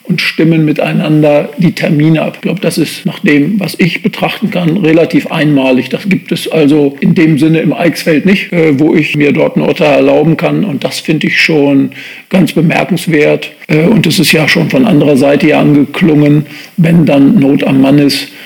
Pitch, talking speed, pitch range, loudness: 155 Hz, 190 wpm, 145-170 Hz, -9 LUFS